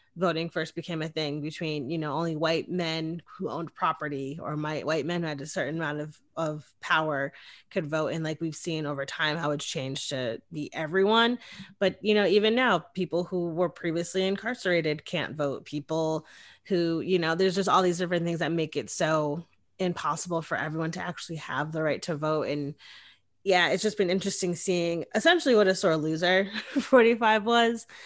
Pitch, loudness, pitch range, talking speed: 165 Hz, -28 LUFS, 155-185 Hz, 190 wpm